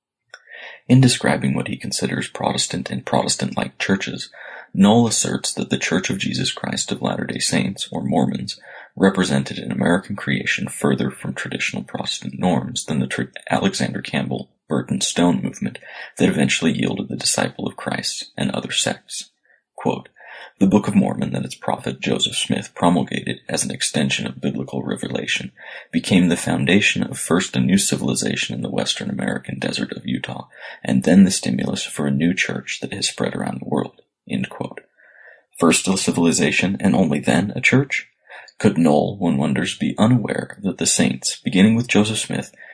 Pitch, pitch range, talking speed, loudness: 95 Hz, 65-110 Hz, 165 wpm, -20 LUFS